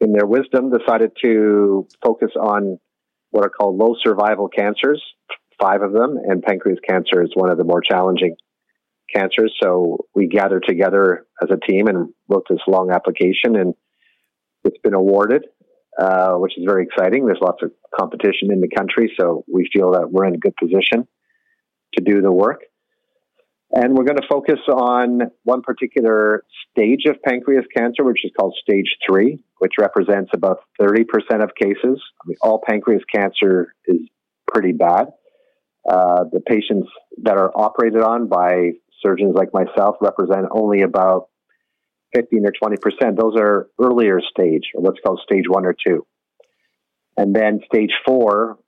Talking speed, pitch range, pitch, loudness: 160 wpm, 95-125 Hz, 110 Hz, -17 LUFS